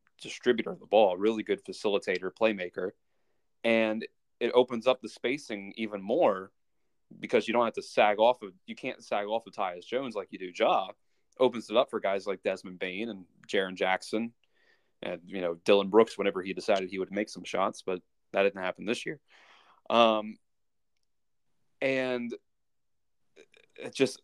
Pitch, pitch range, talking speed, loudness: 110 Hz, 95-125 Hz, 175 wpm, -30 LUFS